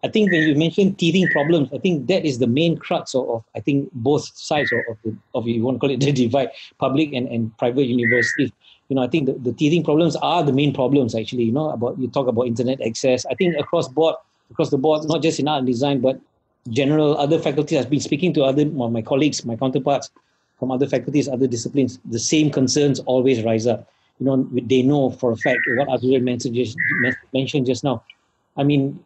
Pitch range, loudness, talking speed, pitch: 125-150 Hz, -20 LUFS, 225 wpm, 135 Hz